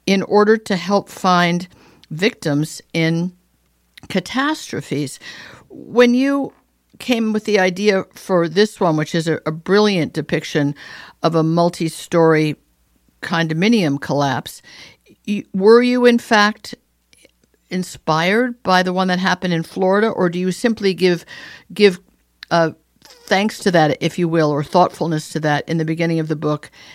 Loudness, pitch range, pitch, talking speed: -17 LUFS, 160-205 Hz, 180 Hz, 145 wpm